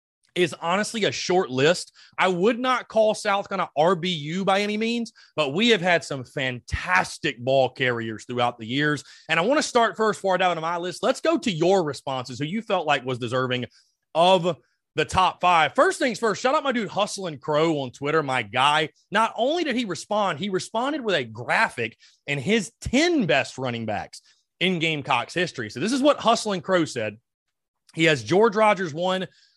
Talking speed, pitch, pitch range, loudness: 195 wpm, 180 Hz, 145-215 Hz, -23 LUFS